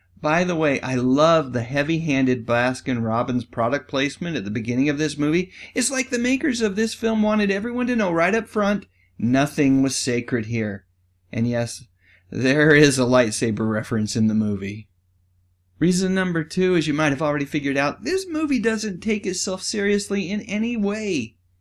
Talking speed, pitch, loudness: 180 wpm, 145 Hz, -21 LUFS